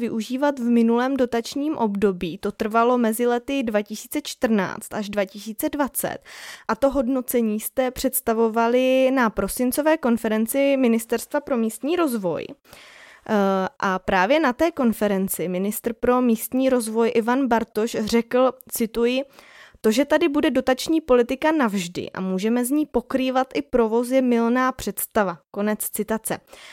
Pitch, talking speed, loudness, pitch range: 235 Hz, 130 wpm, -22 LUFS, 220-265 Hz